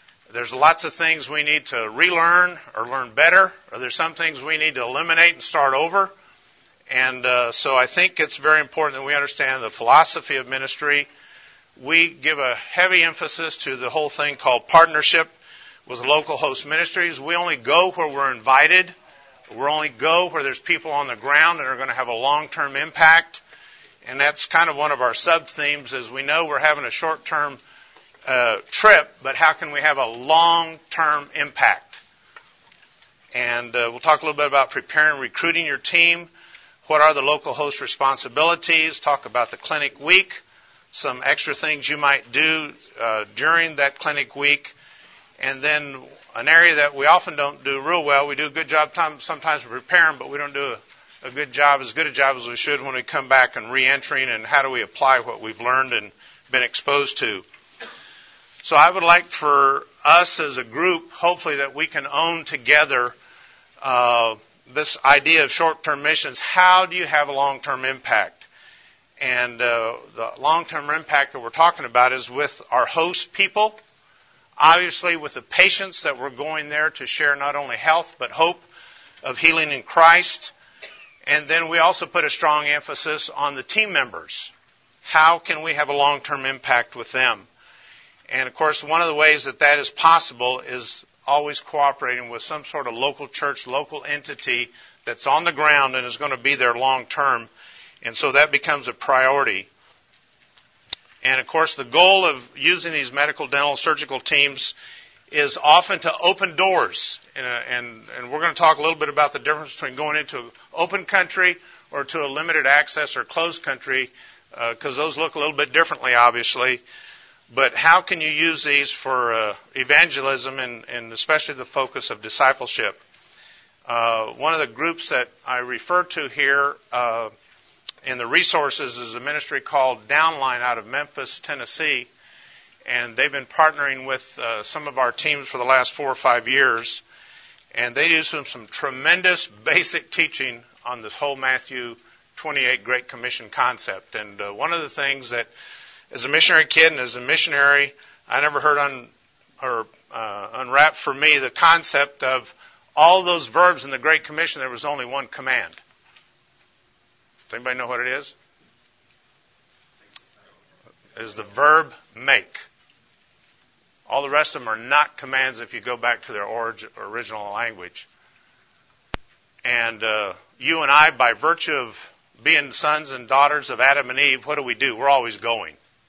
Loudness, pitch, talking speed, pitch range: -19 LUFS, 145 Hz, 180 wpm, 130-160 Hz